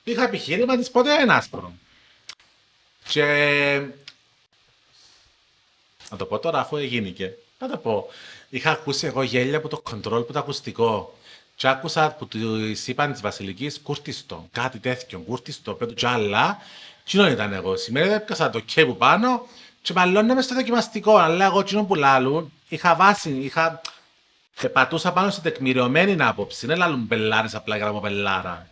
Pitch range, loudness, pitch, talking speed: 120-195 Hz, -21 LUFS, 145 Hz, 155 wpm